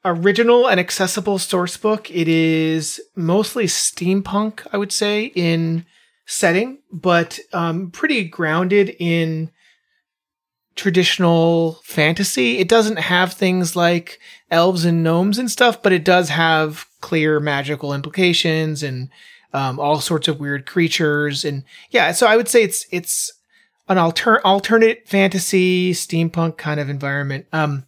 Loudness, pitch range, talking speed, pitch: -17 LUFS, 160-205 Hz, 135 wpm, 175 Hz